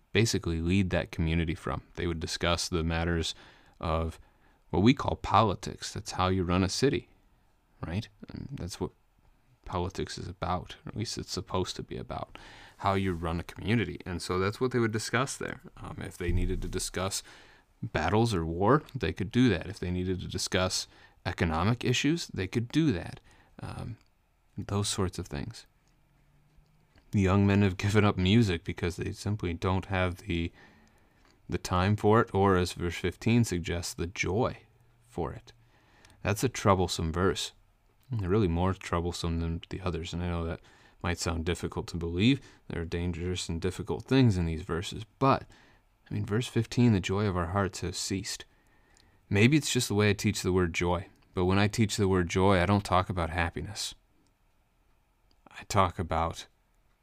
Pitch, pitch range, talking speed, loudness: 95 Hz, 85-105 Hz, 180 wpm, -30 LUFS